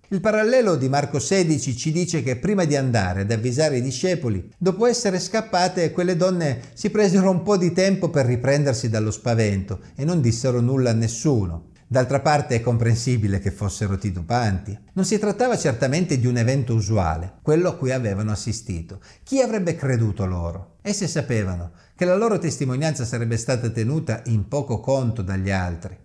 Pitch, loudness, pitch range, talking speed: 130 Hz, -22 LUFS, 110-175 Hz, 170 wpm